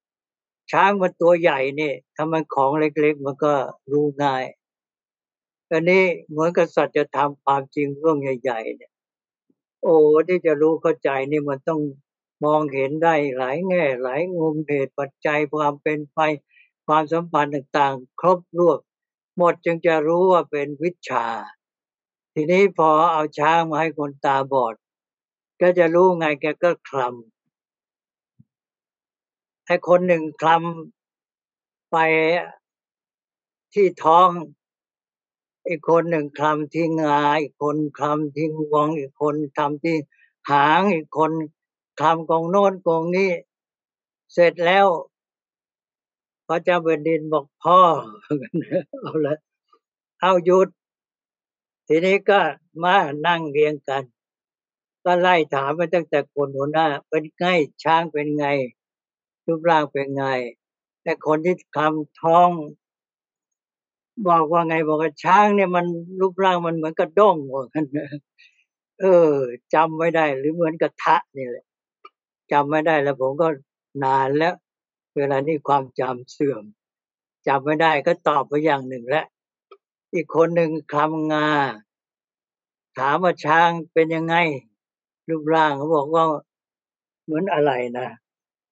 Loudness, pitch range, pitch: -20 LUFS, 145-170 Hz, 155 Hz